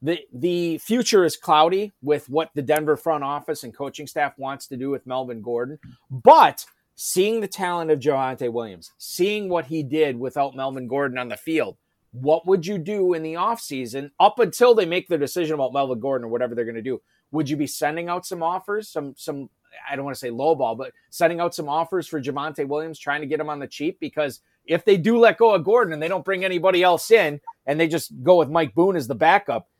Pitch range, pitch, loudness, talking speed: 135-180 Hz, 155 Hz, -22 LUFS, 230 wpm